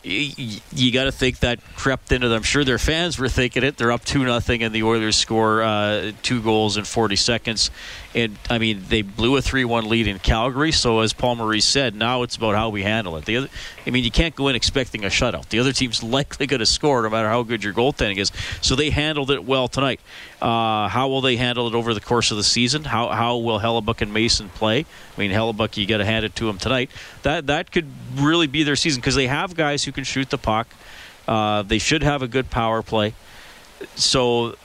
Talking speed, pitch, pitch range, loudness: 235 wpm, 115 Hz, 110-135 Hz, -20 LUFS